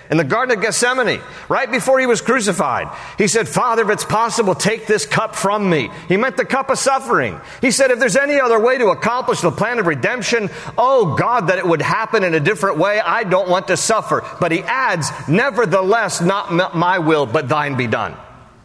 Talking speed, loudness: 210 wpm, -16 LUFS